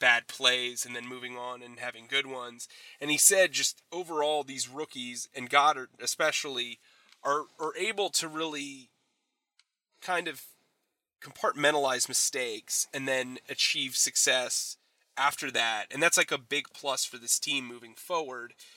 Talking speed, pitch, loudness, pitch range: 145 wpm, 135 Hz, -28 LUFS, 125-150 Hz